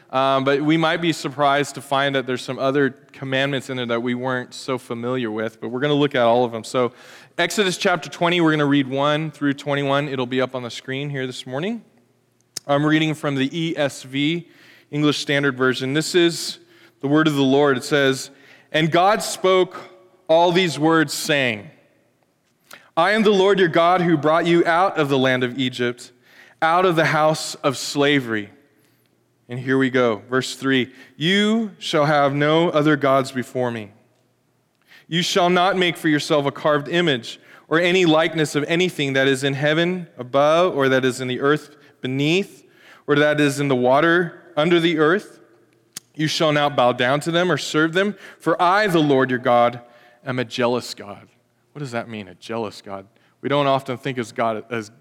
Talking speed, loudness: 195 wpm, -20 LUFS